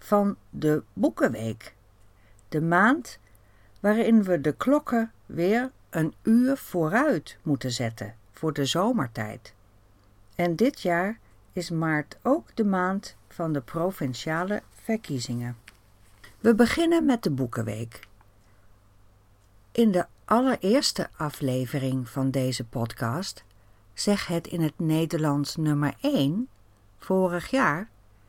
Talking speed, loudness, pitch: 110 wpm, -26 LUFS, 155 Hz